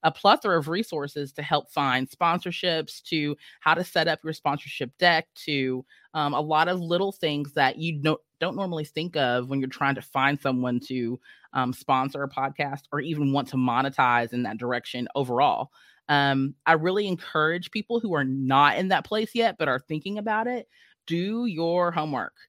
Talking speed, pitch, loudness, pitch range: 185 wpm, 150 Hz, -26 LUFS, 135-170 Hz